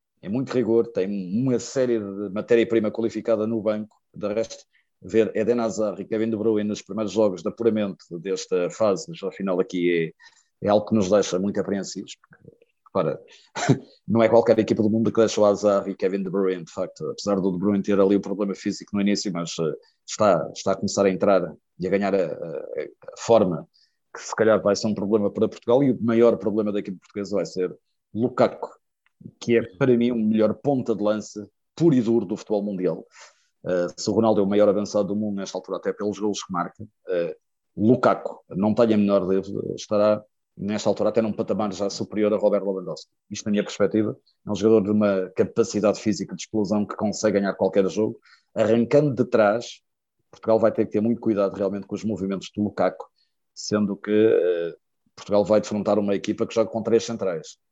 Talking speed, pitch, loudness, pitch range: 205 wpm, 105 Hz, -23 LUFS, 100-115 Hz